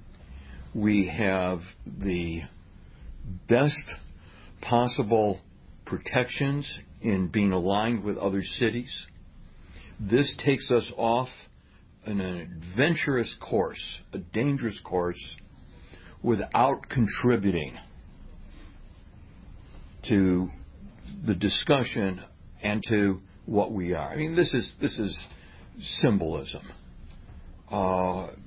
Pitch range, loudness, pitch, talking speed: 85-110 Hz, -27 LUFS, 95 Hz, 85 wpm